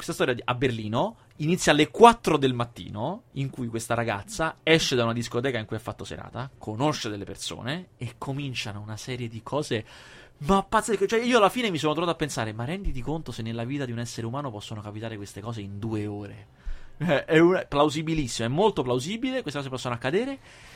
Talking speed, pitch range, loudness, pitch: 210 wpm, 115-155 Hz, -26 LUFS, 125 Hz